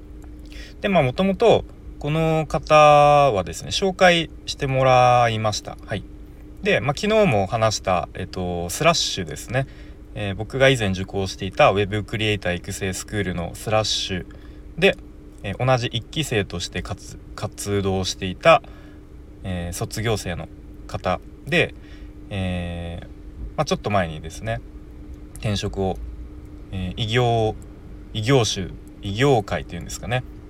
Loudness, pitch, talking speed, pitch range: -21 LUFS, 100 Hz, 270 characters per minute, 90-125 Hz